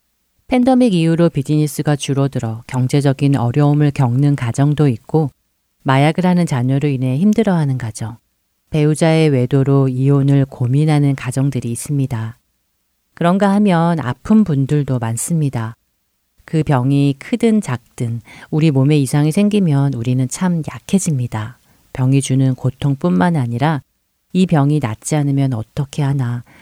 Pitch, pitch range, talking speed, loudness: 140 Hz, 130-155 Hz, 300 characters per minute, -16 LUFS